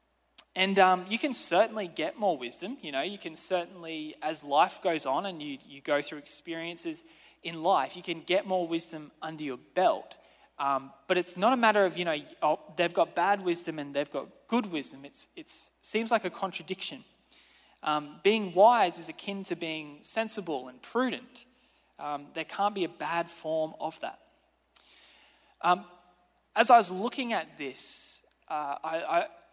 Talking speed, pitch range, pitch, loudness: 175 wpm, 160-205 Hz, 175 Hz, -30 LUFS